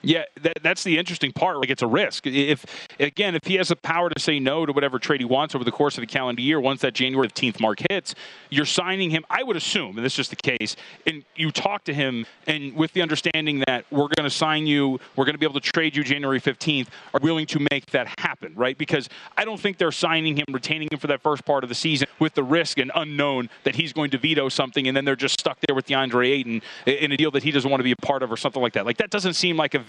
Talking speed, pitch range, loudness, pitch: 285 wpm, 135-160 Hz, -23 LUFS, 145 Hz